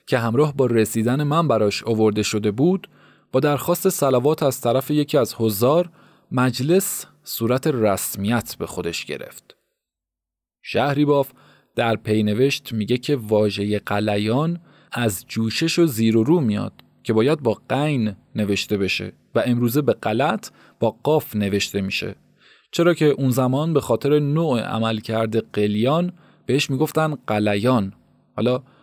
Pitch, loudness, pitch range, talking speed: 120 Hz, -21 LUFS, 105-145 Hz, 135 wpm